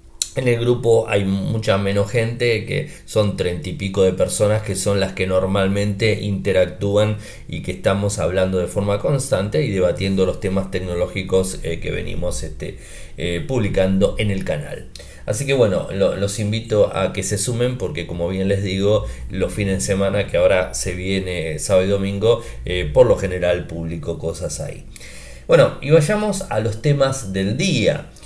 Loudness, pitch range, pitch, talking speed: -19 LUFS, 95-110 Hz, 100 Hz, 175 wpm